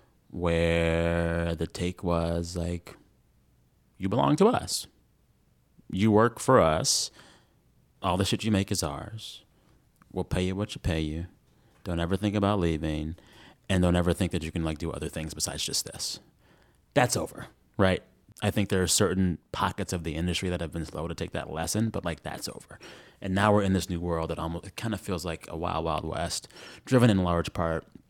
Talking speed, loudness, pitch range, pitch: 195 wpm, -28 LUFS, 80-100 Hz, 85 Hz